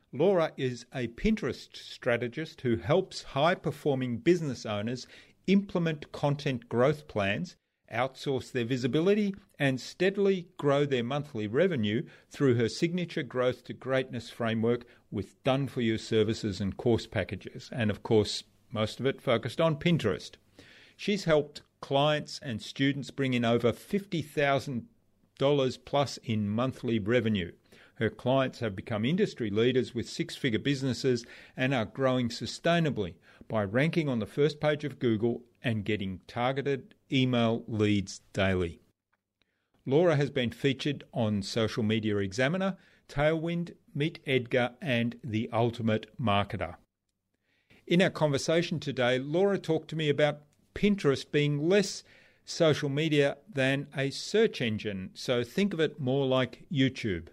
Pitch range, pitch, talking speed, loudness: 115-150 Hz, 130 Hz, 135 wpm, -30 LUFS